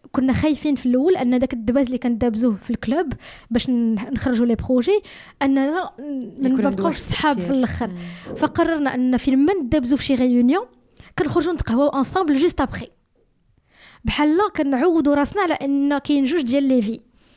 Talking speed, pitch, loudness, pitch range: 155 wpm, 270 Hz, -20 LUFS, 250-305 Hz